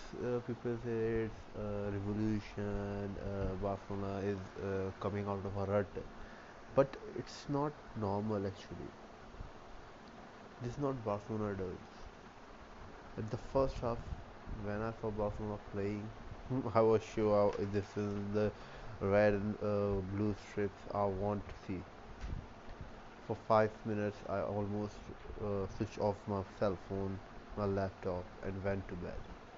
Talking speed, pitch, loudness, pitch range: 135 wpm, 105 Hz, -38 LUFS, 100-110 Hz